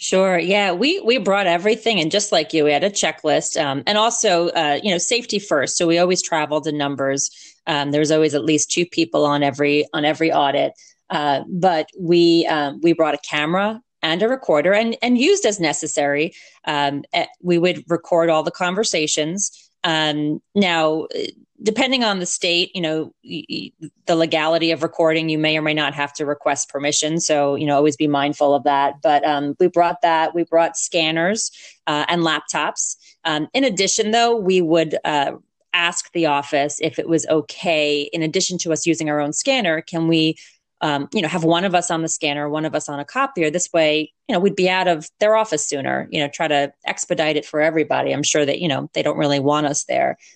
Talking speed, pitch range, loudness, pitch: 205 wpm, 150-180 Hz, -19 LUFS, 165 Hz